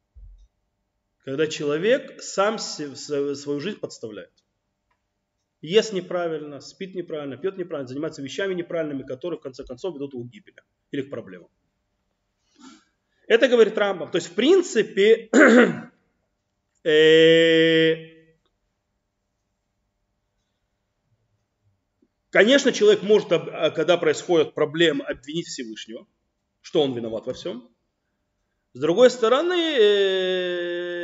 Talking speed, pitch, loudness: 95 wpm, 150 Hz, -21 LUFS